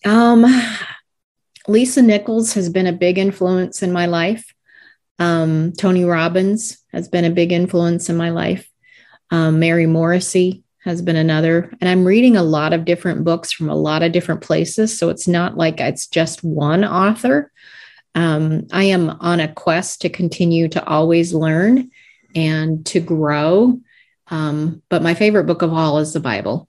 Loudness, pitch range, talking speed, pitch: -16 LUFS, 165-200 Hz, 165 wpm, 175 Hz